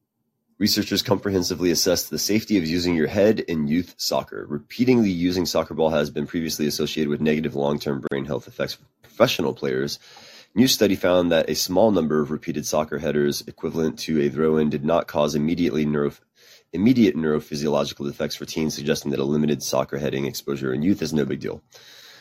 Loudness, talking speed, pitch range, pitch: -22 LUFS, 185 wpm, 75-85 Hz, 75 Hz